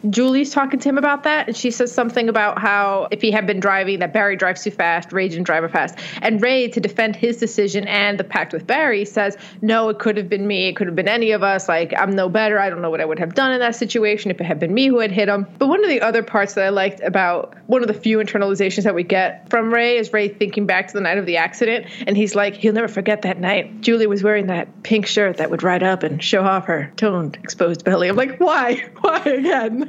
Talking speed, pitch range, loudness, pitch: 275 wpm, 190-230 Hz, -18 LUFS, 210 Hz